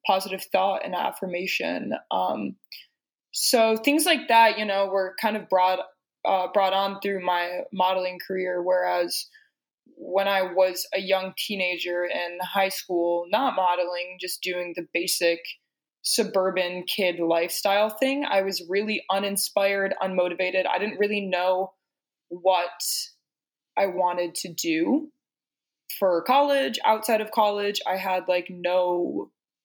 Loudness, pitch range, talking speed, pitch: -25 LUFS, 180-205 Hz, 130 wpm, 190 Hz